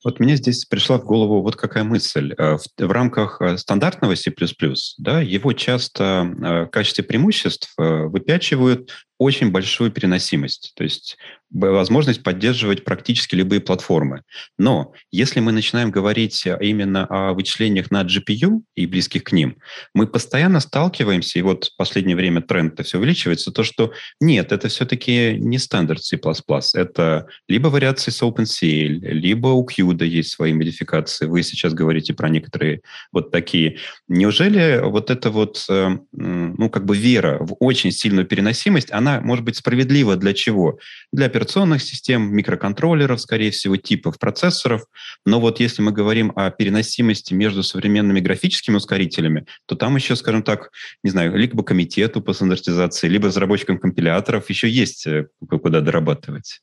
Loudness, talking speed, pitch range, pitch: -18 LUFS, 145 wpm, 95-125 Hz, 105 Hz